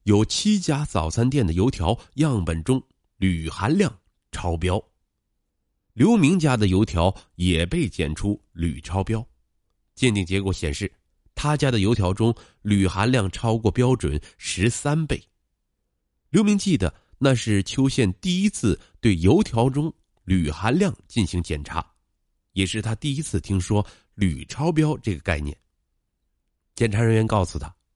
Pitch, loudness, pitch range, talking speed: 100 Hz, -23 LUFS, 90-125 Hz, 205 characters per minute